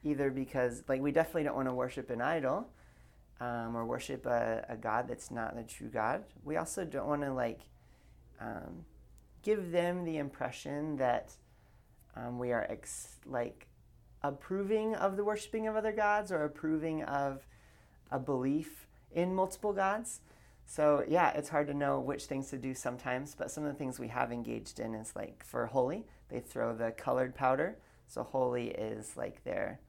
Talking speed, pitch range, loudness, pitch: 175 wpm, 125-160 Hz, -36 LUFS, 140 Hz